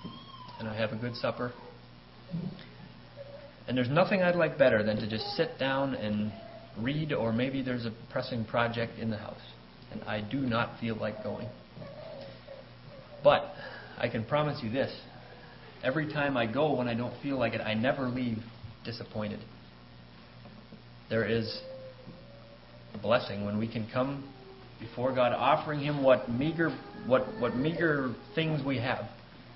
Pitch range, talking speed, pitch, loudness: 105-130 Hz, 150 wpm, 120 Hz, -31 LUFS